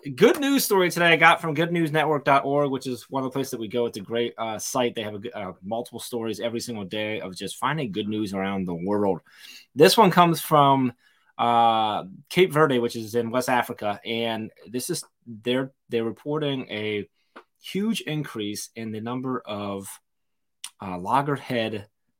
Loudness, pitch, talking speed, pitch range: -24 LUFS, 120 Hz, 175 wpm, 110-145 Hz